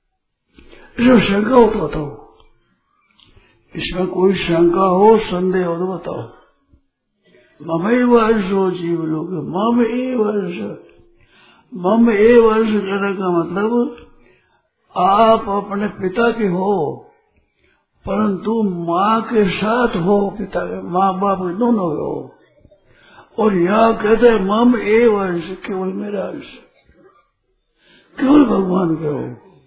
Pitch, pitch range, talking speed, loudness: 200 Hz, 185-225 Hz, 115 wpm, -16 LUFS